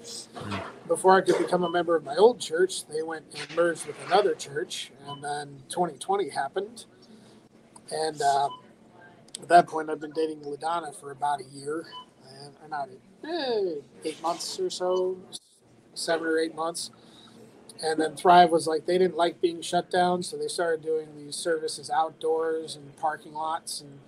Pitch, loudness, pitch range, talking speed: 165 Hz, -27 LUFS, 155-180 Hz, 170 wpm